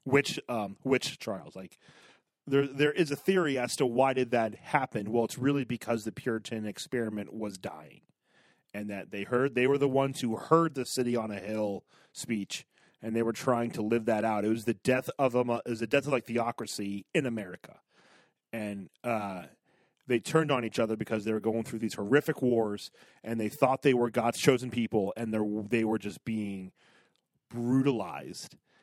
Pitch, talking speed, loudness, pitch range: 115 Hz, 195 wpm, -30 LUFS, 110-130 Hz